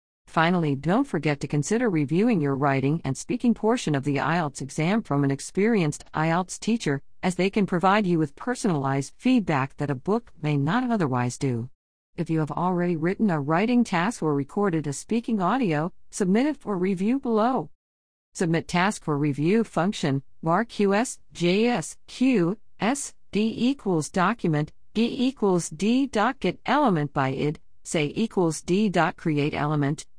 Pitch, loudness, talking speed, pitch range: 175 Hz, -25 LUFS, 160 wpm, 145-215 Hz